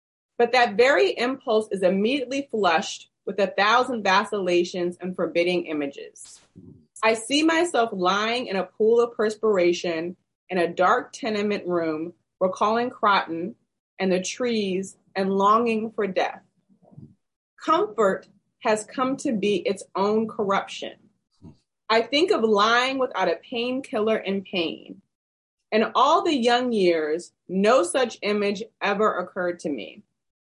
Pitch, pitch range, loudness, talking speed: 210 Hz, 185-240 Hz, -23 LUFS, 130 wpm